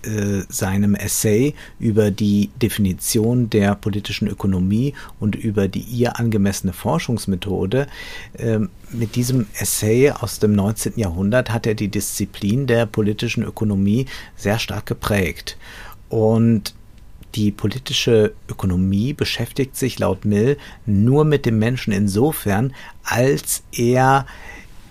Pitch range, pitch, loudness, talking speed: 100-120 Hz, 110 Hz, -19 LUFS, 110 wpm